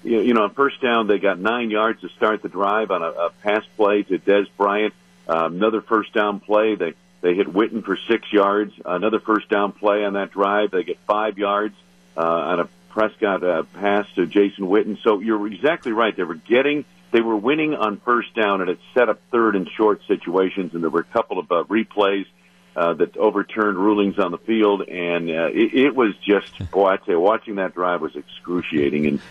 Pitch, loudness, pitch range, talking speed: 100 Hz, -20 LUFS, 90-110 Hz, 215 wpm